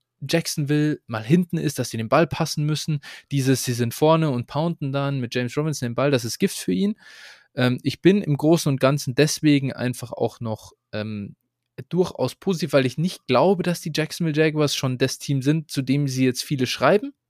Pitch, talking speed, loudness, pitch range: 140 Hz, 205 wpm, -22 LUFS, 125-160 Hz